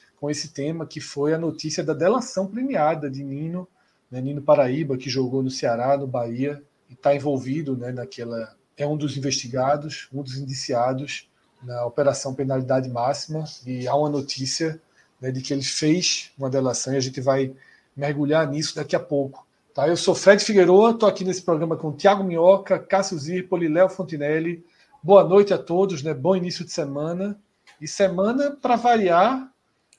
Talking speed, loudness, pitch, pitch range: 170 wpm, -22 LUFS, 150 Hz, 135-180 Hz